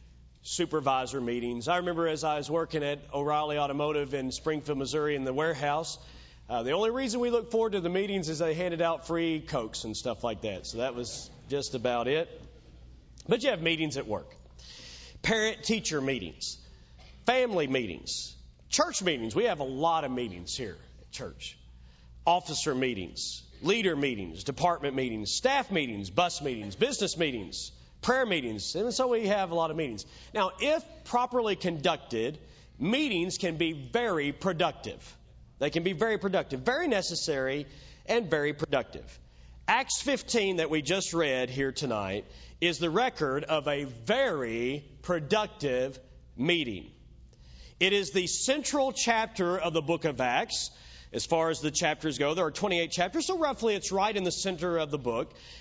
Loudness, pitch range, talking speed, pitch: -30 LUFS, 120-180 Hz, 165 wpm, 150 Hz